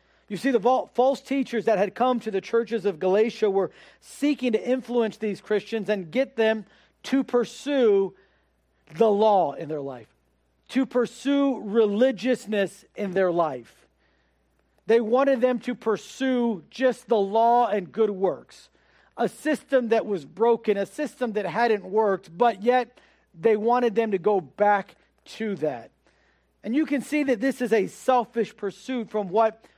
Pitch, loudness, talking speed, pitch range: 225 Hz, -24 LUFS, 155 wpm, 195-245 Hz